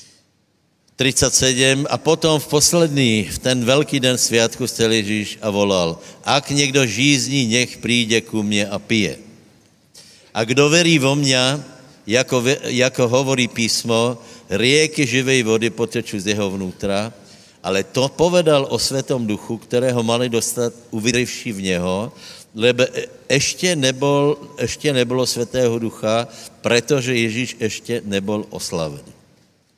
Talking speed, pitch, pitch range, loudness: 125 wpm, 125 Hz, 110-135 Hz, -18 LUFS